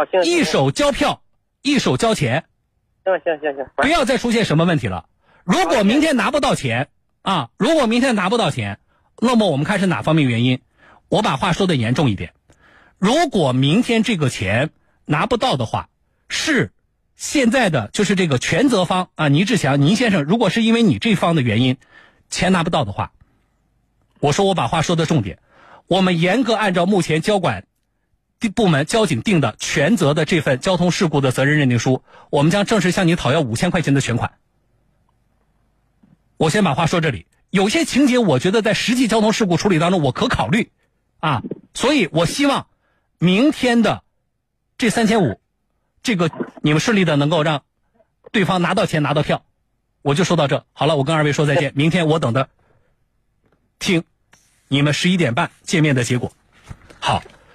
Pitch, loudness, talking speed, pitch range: 165 Hz, -18 LUFS, 265 characters per minute, 130-205 Hz